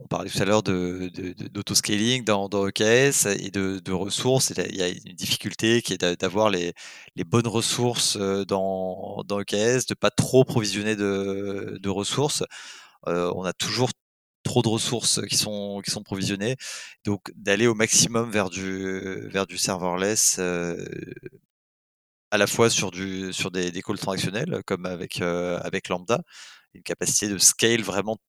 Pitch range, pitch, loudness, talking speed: 95-110 Hz, 100 Hz, -24 LUFS, 170 wpm